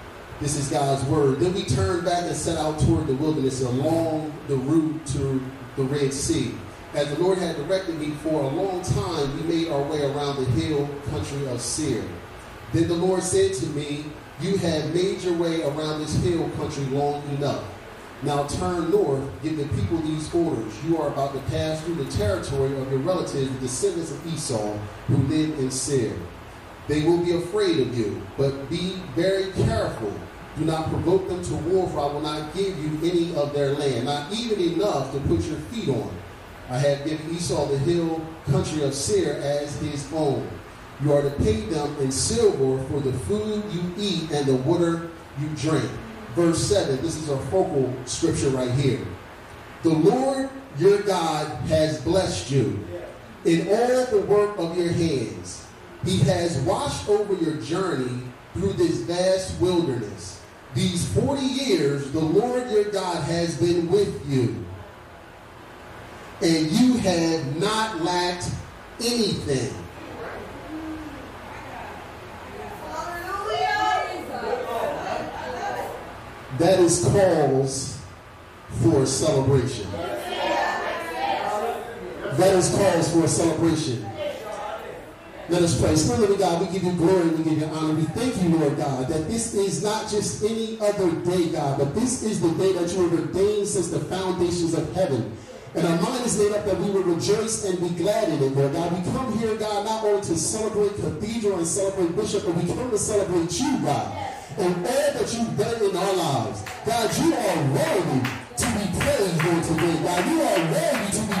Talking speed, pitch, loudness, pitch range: 170 wpm, 160 Hz, -24 LUFS, 140-185 Hz